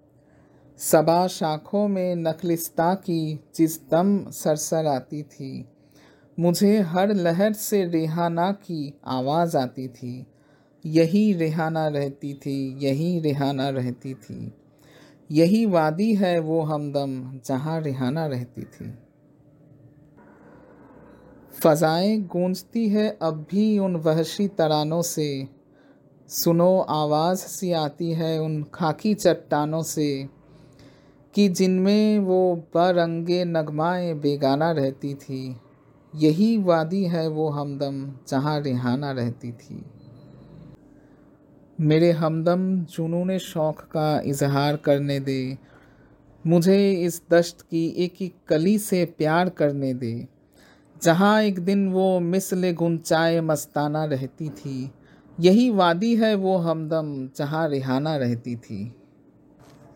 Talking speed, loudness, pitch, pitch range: 105 wpm, -23 LUFS, 160 Hz, 140-175 Hz